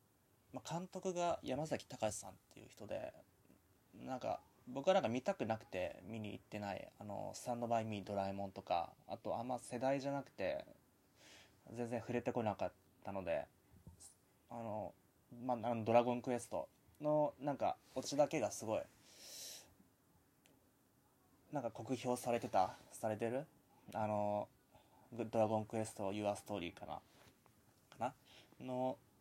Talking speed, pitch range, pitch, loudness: 280 characters per minute, 105-130 Hz, 115 Hz, -42 LUFS